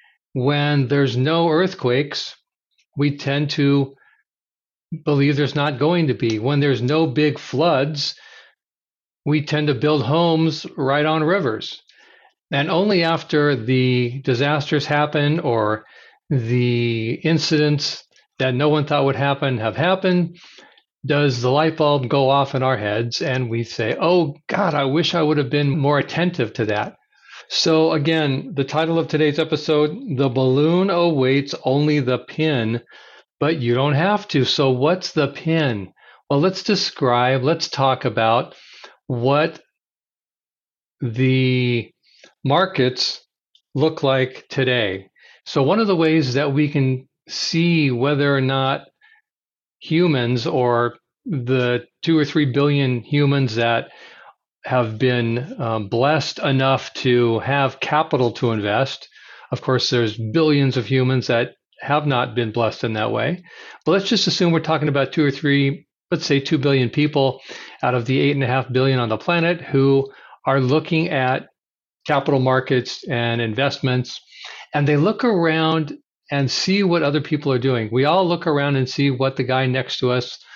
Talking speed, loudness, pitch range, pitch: 150 wpm, -19 LUFS, 130-155 Hz, 140 Hz